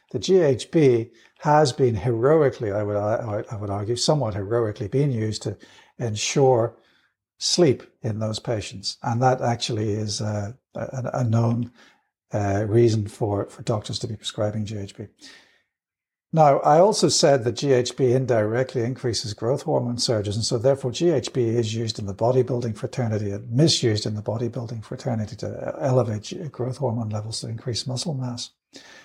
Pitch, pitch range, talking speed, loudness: 120 Hz, 110-130 Hz, 150 wpm, -23 LUFS